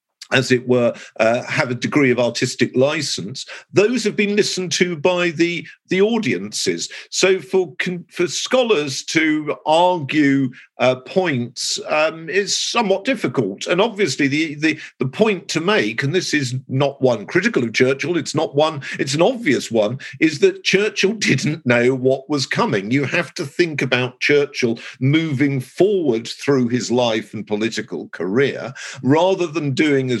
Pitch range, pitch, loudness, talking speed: 130-185 Hz, 150 Hz, -18 LUFS, 160 wpm